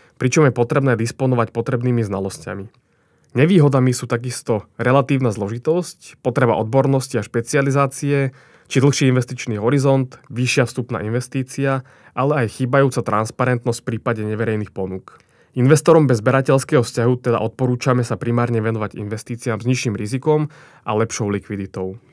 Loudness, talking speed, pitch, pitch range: -19 LUFS, 125 wpm, 125 Hz, 115-135 Hz